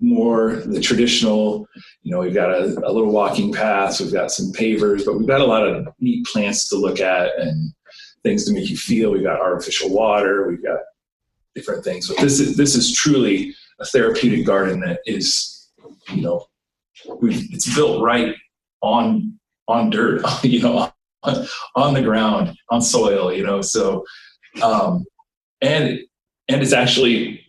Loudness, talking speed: -18 LUFS, 170 wpm